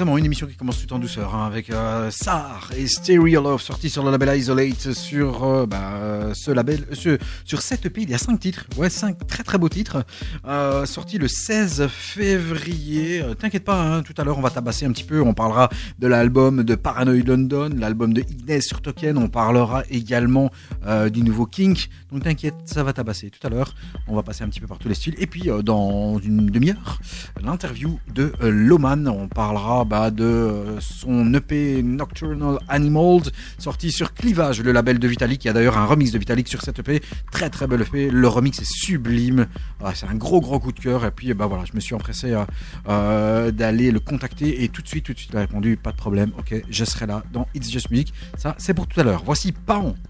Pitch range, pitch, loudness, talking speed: 110-150 Hz, 125 Hz, -21 LUFS, 220 wpm